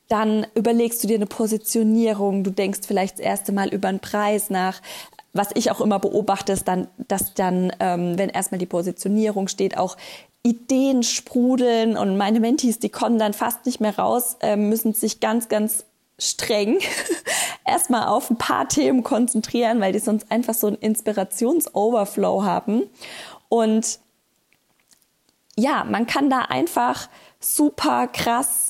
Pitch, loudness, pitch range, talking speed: 220 Hz, -21 LUFS, 200-240 Hz, 150 wpm